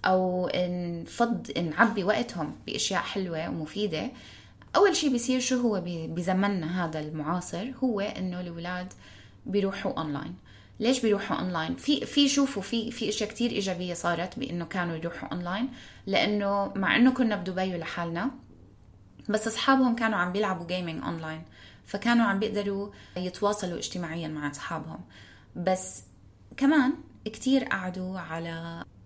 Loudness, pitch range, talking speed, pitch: -28 LUFS, 165-225 Hz, 130 wpm, 185 Hz